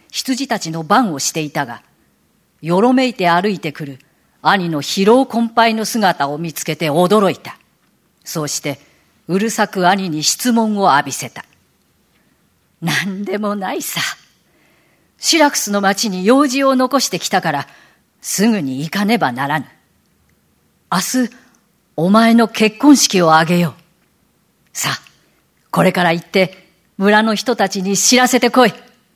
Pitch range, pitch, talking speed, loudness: 170-230 Hz, 200 Hz, 250 characters per minute, -15 LUFS